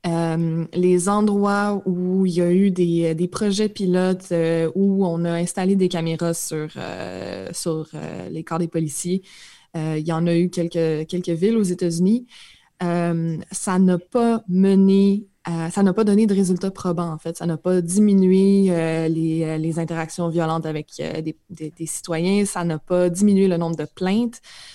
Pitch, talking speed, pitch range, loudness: 175 Hz, 185 wpm, 165-195 Hz, -21 LUFS